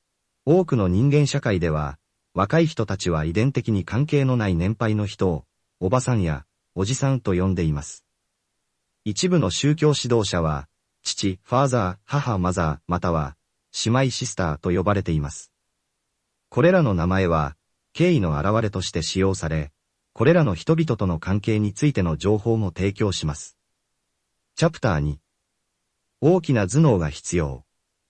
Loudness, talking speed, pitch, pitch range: -22 LUFS, 290 characters per minute, 100 Hz, 85-125 Hz